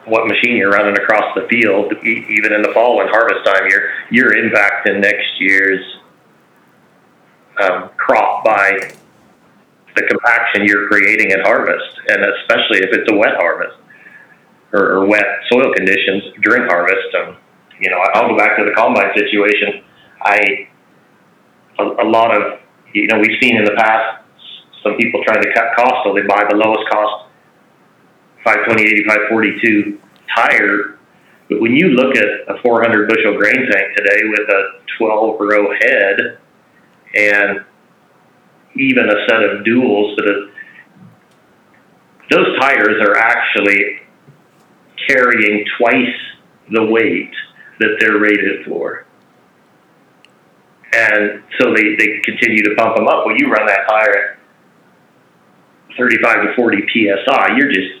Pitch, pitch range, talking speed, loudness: 105 Hz, 105-115 Hz, 140 wpm, -12 LUFS